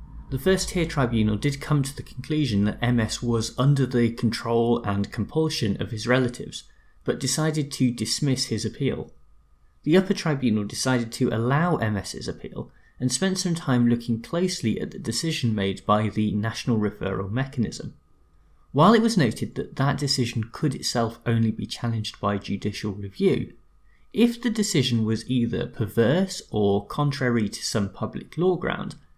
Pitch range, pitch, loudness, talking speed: 110-145 Hz, 120 Hz, -25 LUFS, 160 wpm